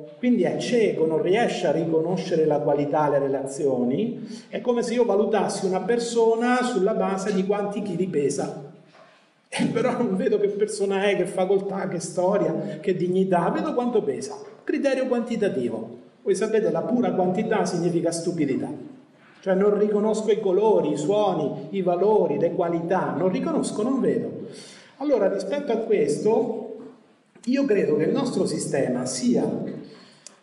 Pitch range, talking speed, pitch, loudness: 180-235 Hz, 150 wpm, 205 Hz, -23 LUFS